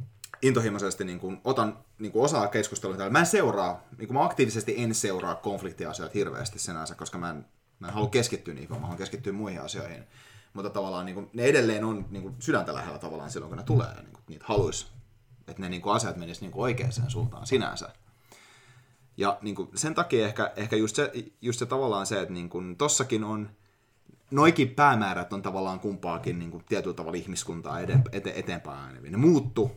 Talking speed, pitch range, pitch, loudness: 190 wpm, 95-125 Hz, 110 Hz, -28 LUFS